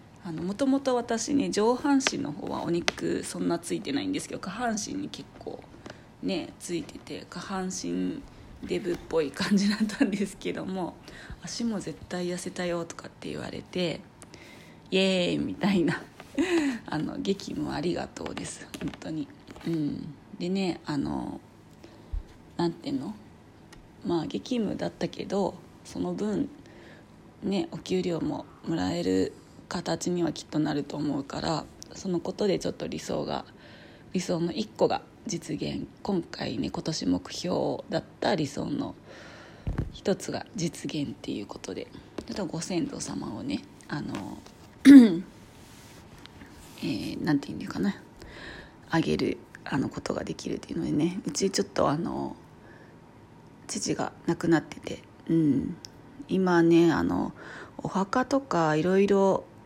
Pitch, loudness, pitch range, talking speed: 185 Hz, -28 LUFS, 165-235 Hz, 260 characters per minute